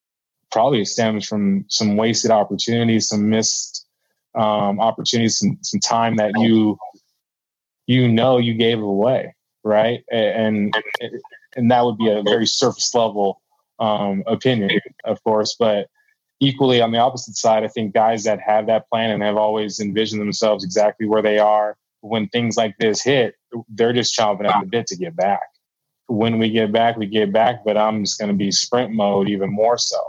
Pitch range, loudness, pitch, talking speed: 105-115 Hz, -18 LUFS, 110 Hz, 175 wpm